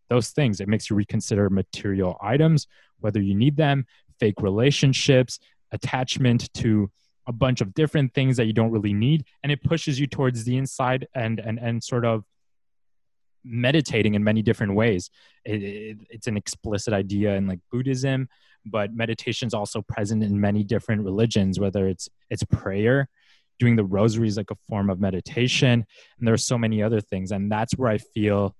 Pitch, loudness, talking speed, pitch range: 115 Hz, -24 LUFS, 180 wpm, 105-125 Hz